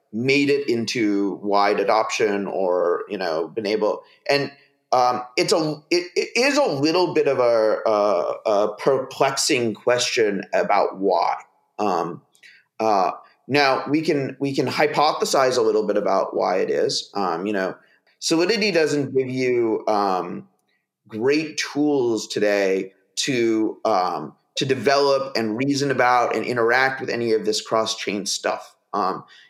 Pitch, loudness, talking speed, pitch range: 135 Hz, -21 LUFS, 145 wpm, 115-155 Hz